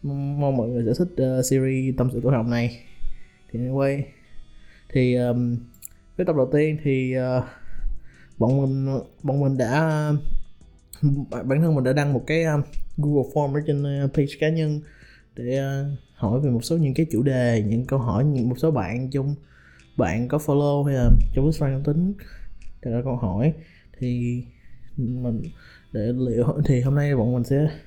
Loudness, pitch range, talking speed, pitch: -23 LUFS, 120-145 Hz, 185 wpm, 130 Hz